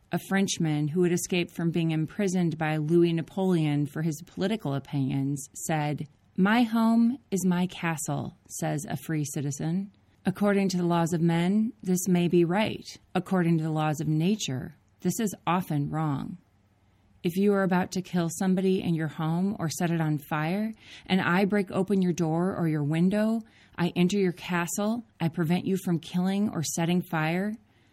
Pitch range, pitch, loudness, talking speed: 155-190 Hz, 175 Hz, -27 LUFS, 175 wpm